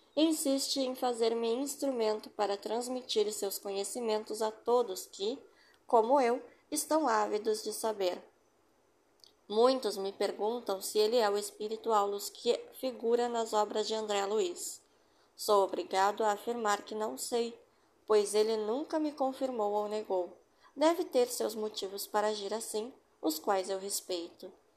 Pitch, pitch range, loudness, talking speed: 220 Hz, 205-255 Hz, -33 LUFS, 140 wpm